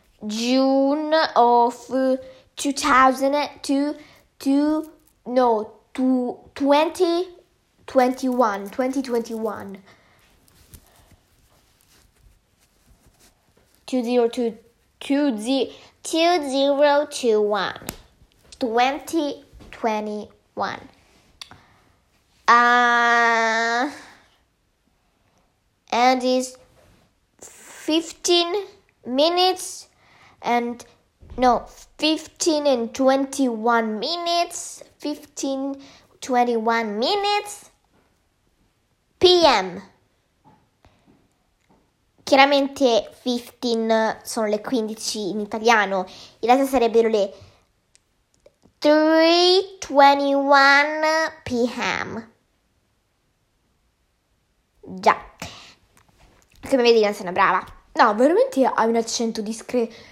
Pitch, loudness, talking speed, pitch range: 255 Hz, -20 LUFS, 70 wpm, 225-290 Hz